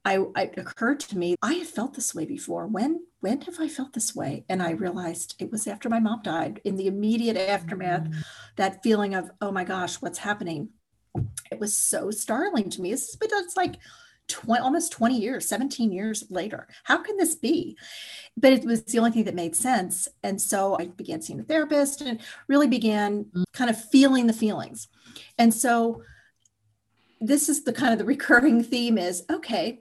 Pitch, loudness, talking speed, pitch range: 225 Hz, -25 LUFS, 195 wpm, 195-270 Hz